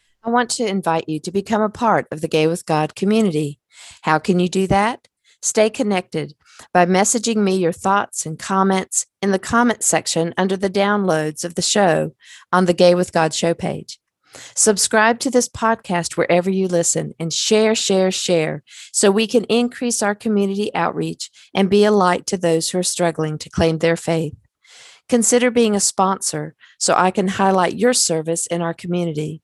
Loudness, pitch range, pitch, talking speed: -18 LUFS, 165-210 Hz, 190 Hz, 185 wpm